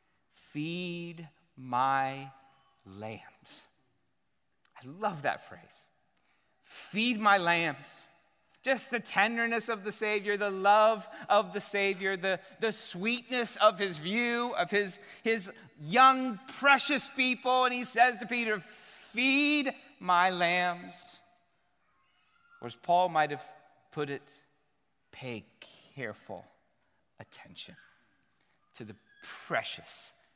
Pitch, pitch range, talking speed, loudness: 205 Hz, 175-240 Hz, 105 wpm, -29 LUFS